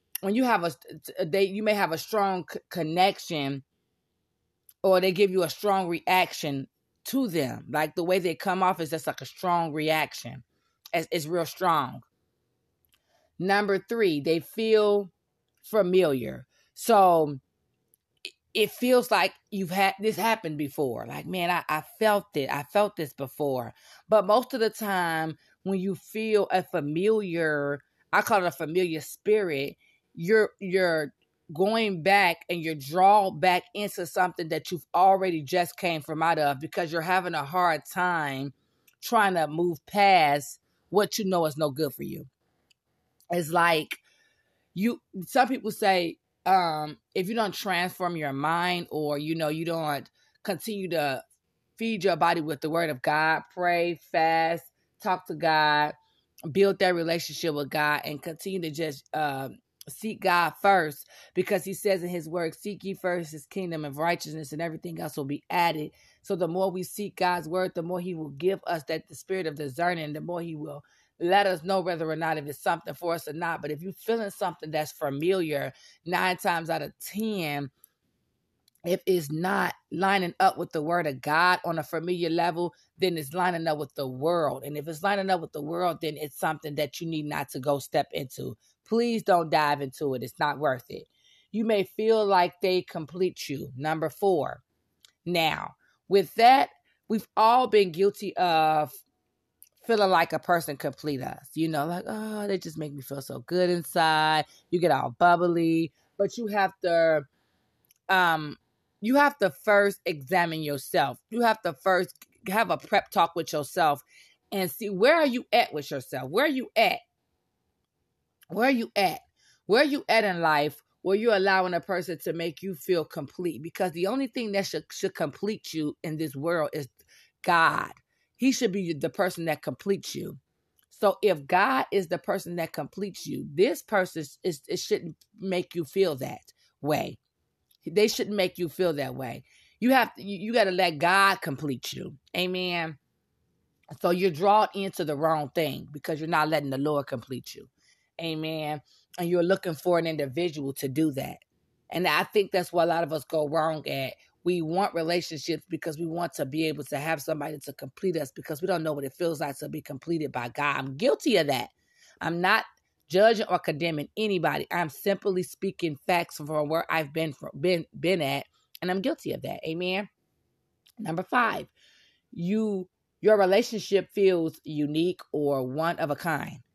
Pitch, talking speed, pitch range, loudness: 175 Hz, 180 wpm, 155-195 Hz, -27 LUFS